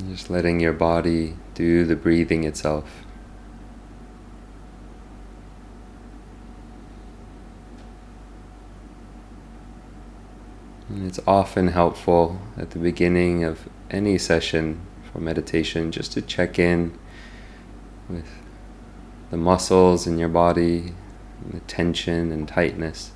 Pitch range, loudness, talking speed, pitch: 80-95 Hz, -22 LUFS, 90 wpm, 85 Hz